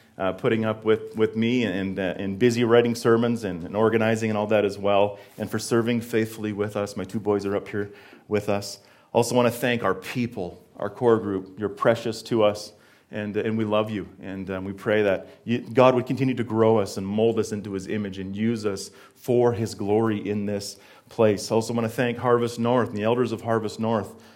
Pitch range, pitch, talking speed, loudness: 100-115 Hz, 110 Hz, 225 wpm, -24 LUFS